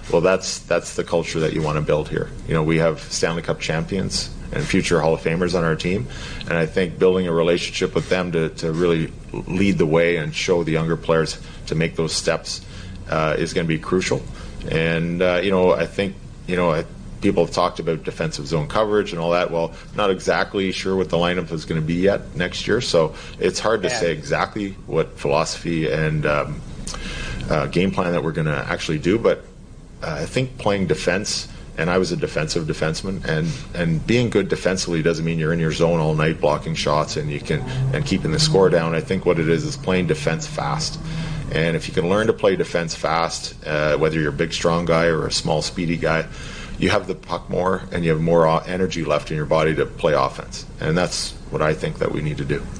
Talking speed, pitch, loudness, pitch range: 225 wpm, 85 Hz, -21 LUFS, 80-95 Hz